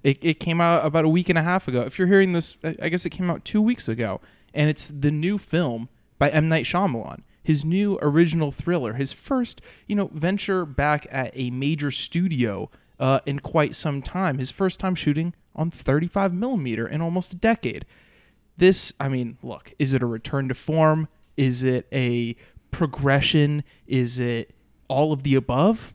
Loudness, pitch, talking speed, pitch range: -23 LUFS, 150 Hz, 190 wpm, 135-175 Hz